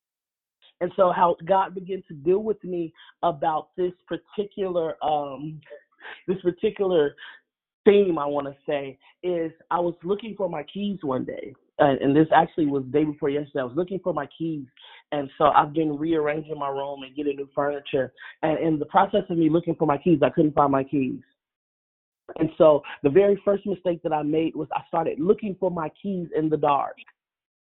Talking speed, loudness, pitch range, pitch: 195 wpm, -24 LUFS, 145-180 Hz, 160 Hz